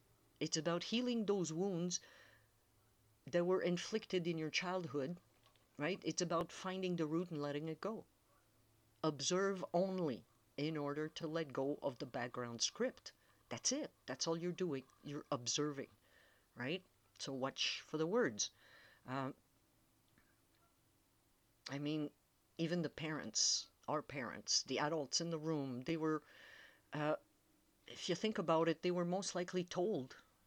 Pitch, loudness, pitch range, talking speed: 155 Hz, -41 LUFS, 135-180 Hz, 140 wpm